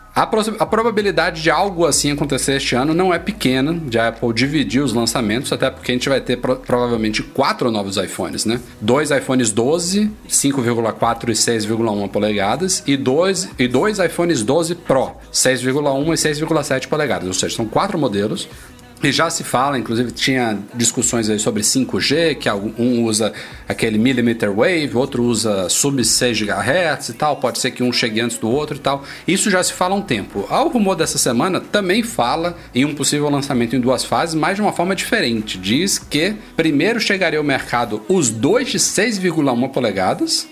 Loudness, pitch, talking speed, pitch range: -17 LUFS, 135 Hz, 175 wpm, 120-165 Hz